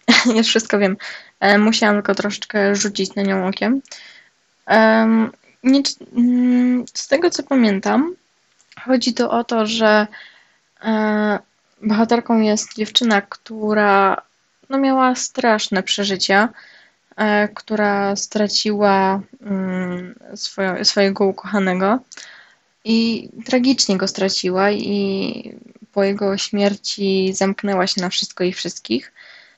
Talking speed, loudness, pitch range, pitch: 95 wpm, -18 LUFS, 200-230 Hz, 210 Hz